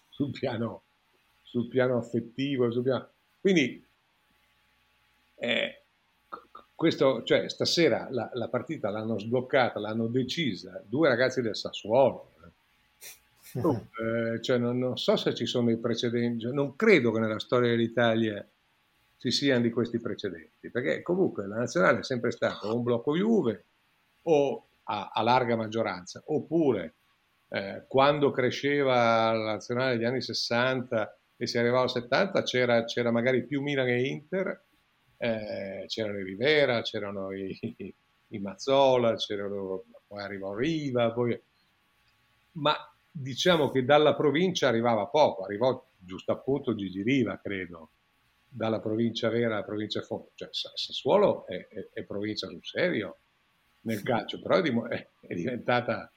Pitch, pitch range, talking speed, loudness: 120 Hz, 110-130 Hz, 135 wpm, -28 LUFS